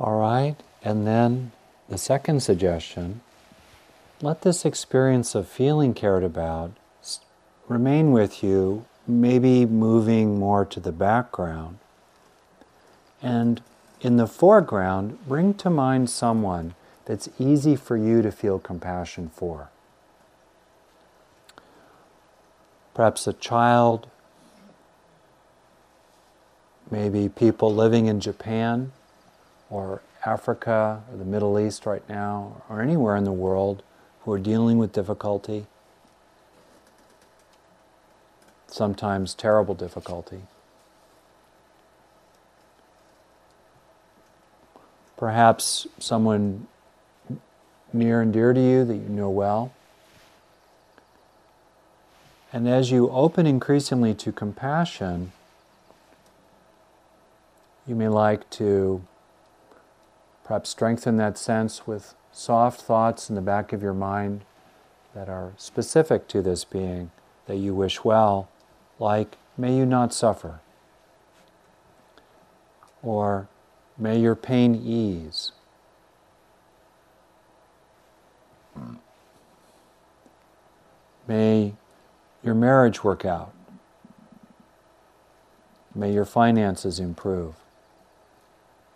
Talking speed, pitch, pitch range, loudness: 90 wpm, 110 Hz, 100-120 Hz, -23 LUFS